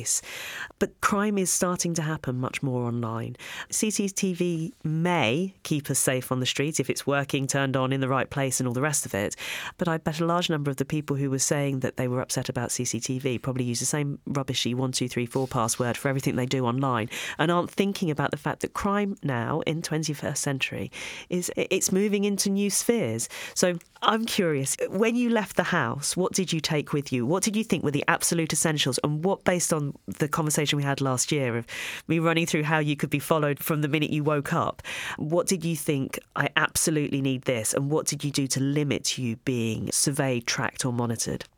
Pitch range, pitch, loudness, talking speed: 130-170 Hz, 145 Hz, -26 LUFS, 220 wpm